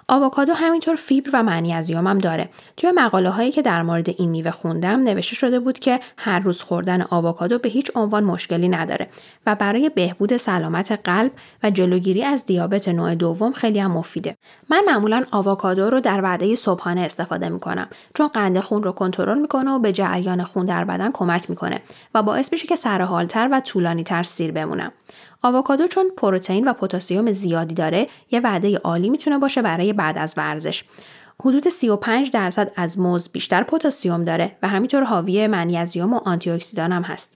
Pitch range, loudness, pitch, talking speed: 175-250 Hz, -20 LUFS, 200 Hz, 175 wpm